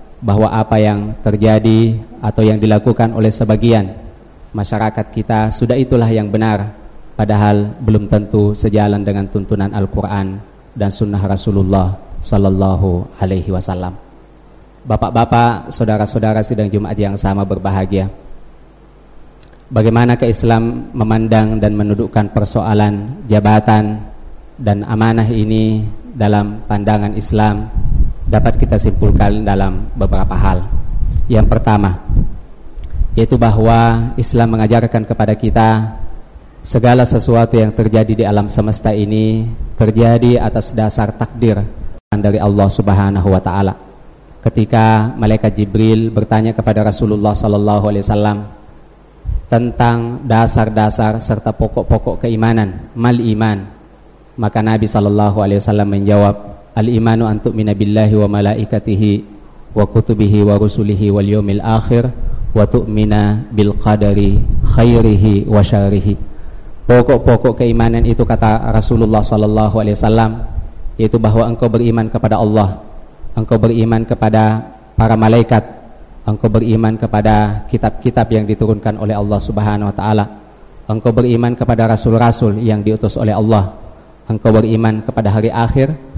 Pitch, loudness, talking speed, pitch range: 110 Hz, -13 LUFS, 110 wpm, 105-115 Hz